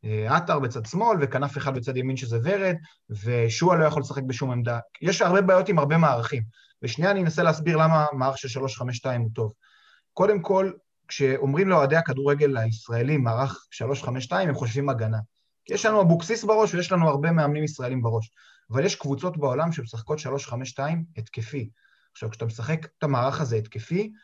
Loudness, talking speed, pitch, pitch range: -24 LUFS, 165 wpm, 140 Hz, 120-165 Hz